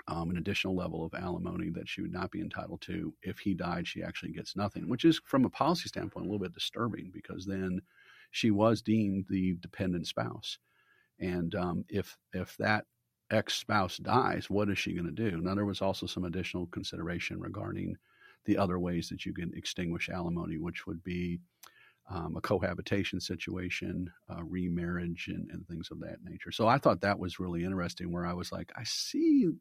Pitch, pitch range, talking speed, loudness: 90 Hz, 85-100 Hz, 195 wpm, -34 LUFS